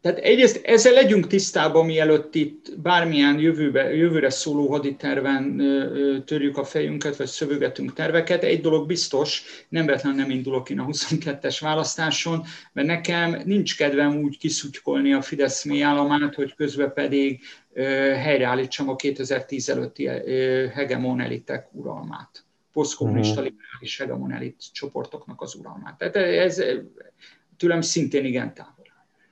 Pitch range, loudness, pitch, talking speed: 135-160 Hz, -22 LUFS, 145 Hz, 120 wpm